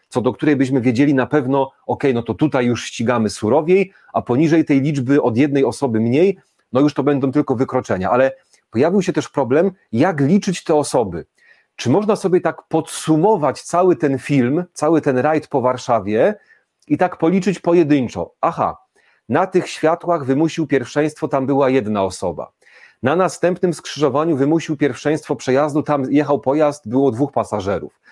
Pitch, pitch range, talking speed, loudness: 145 Hz, 130-165 Hz, 165 wpm, -17 LUFS